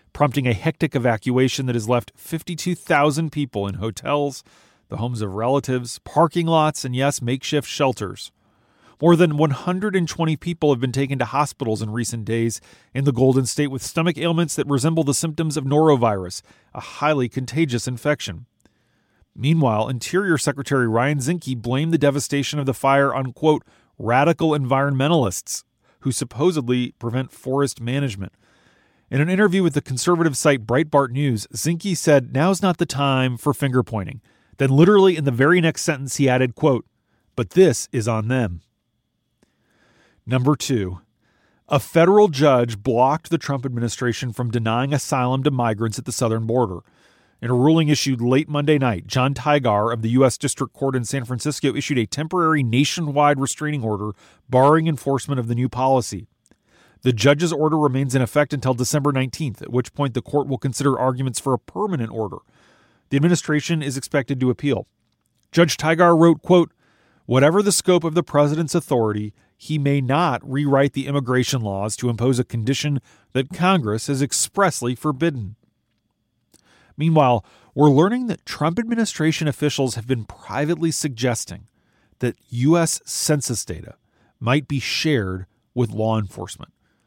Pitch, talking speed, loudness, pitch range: 135 Hz, 155 wpm, -20 LUFS, 120-150 Hz